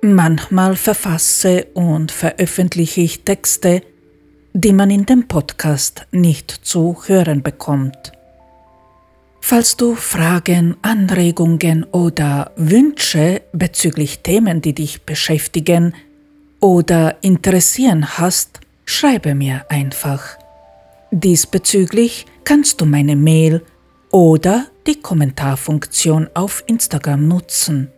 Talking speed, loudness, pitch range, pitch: 90 wpm, -14 LUFS, 150-195 Hz, 170 Hz